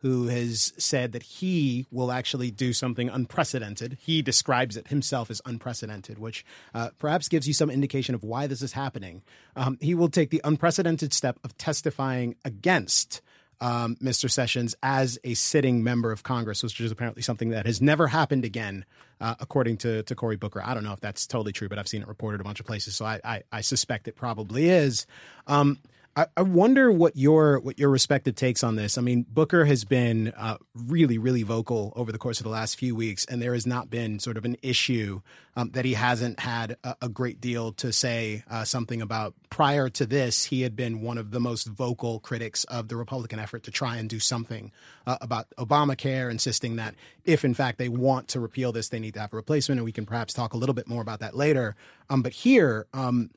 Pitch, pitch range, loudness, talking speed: 120 Hz, 115-135 Hz, -26 LUFS, 220 wpm